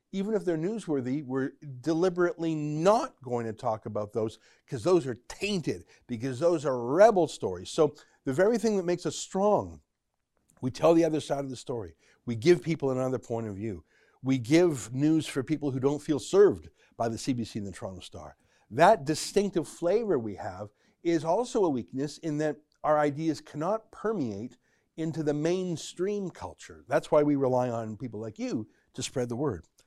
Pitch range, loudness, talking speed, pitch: 125-170 Hz, -29 LUFS, 185 wpm, 150 Hz